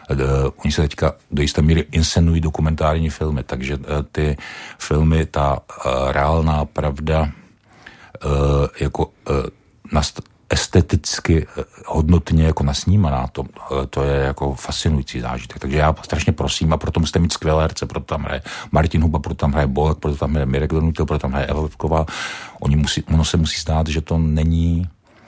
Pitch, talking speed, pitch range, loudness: 75 Hz, 165 wpm, 70-80 Hz, -19 LUFS